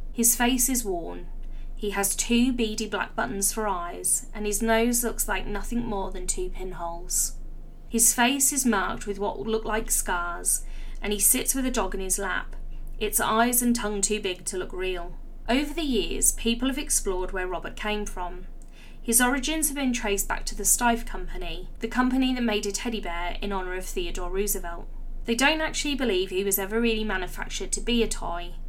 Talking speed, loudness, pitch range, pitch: 200 wpm, -25 LUFS, 190-240 Hz, 215 Hz